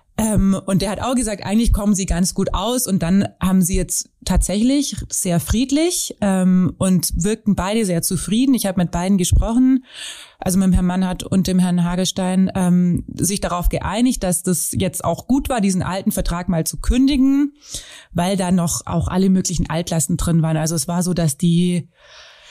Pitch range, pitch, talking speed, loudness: 175-210 Hz, 185 Hz, 190 wpm, -18 LUFS